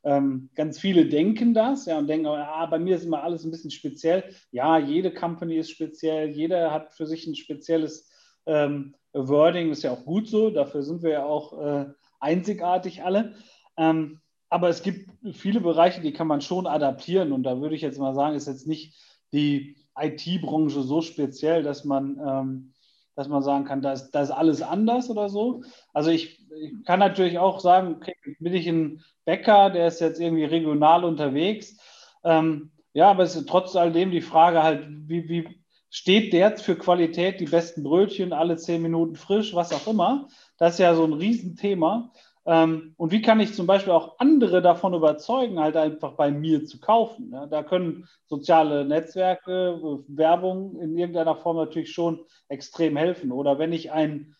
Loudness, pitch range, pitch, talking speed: -23 LUFS, 150-180 Hz, 165 Hz, 185 wpm